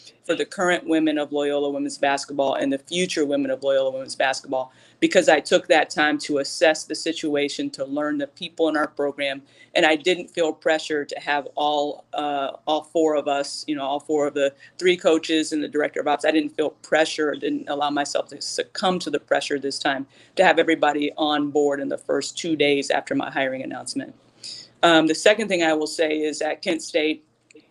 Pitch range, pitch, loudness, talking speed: 140-160 Hz, 150 Hz, -22 LUFS, 210 wpm